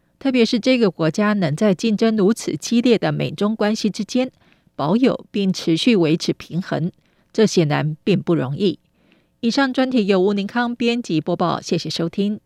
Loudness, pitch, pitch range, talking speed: -19 LUFS, 205 Hz, 170-230 Hz, 260 characters per minute